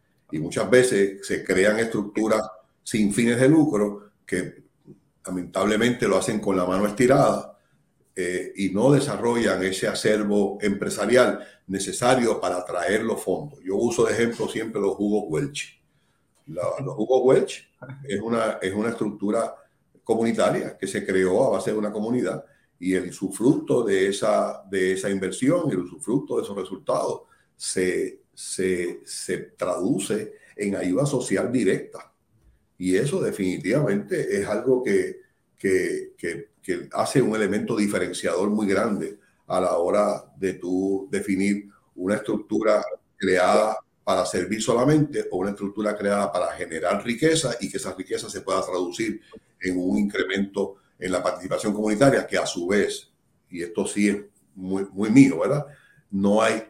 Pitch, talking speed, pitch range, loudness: 105 Hz, 150 wpm, 95-120 Hz, -24 LUFS